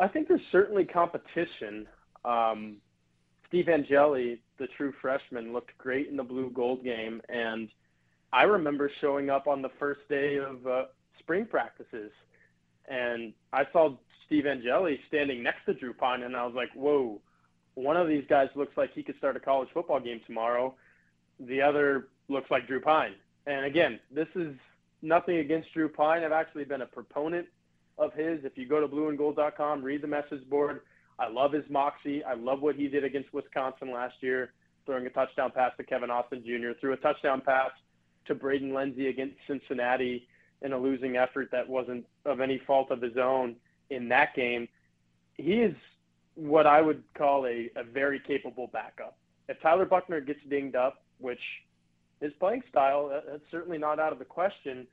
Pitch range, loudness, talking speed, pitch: 120-145 Hz, -30 LUFS, 180 wpm, 135 Hz